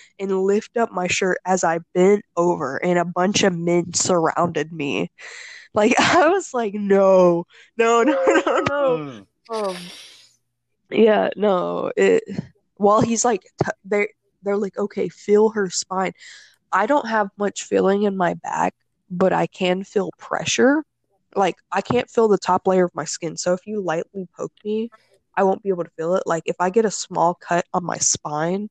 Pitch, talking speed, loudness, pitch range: 195 Hz, 180 wpm, -20 LUFS, 175-215 Hz